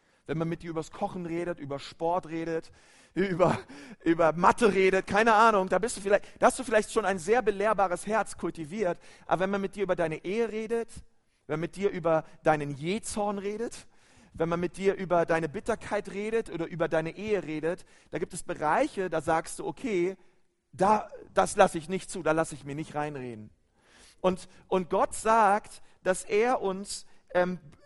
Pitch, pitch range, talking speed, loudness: 180 Hz, 165-205 Hz, 190 wpm, -29 LUFS